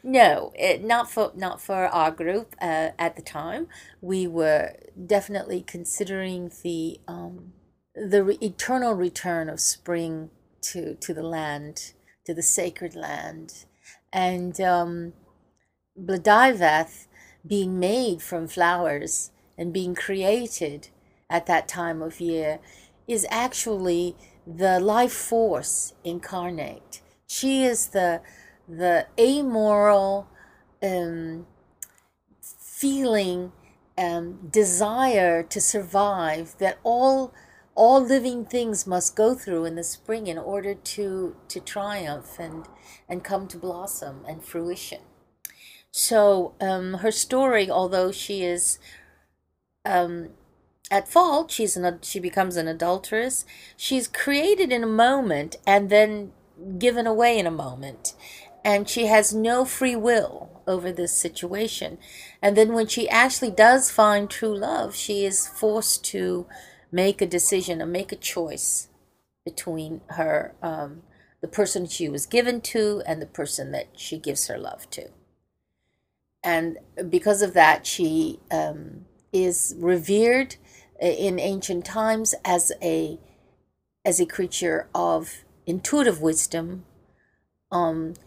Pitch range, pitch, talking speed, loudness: 170-220 Hz, 190 Hz, 125 wpm, -23 LUFS